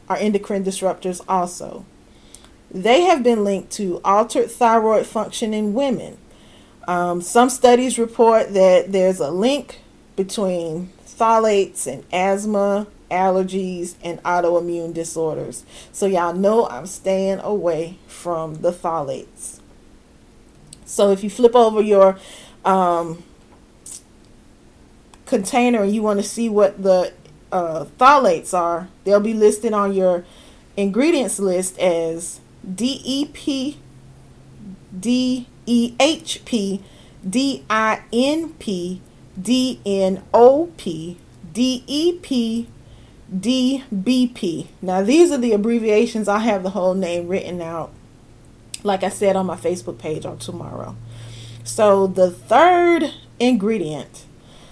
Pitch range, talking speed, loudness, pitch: 180-235 Hz, 120 wpm, -19 LUFS, 195 Hz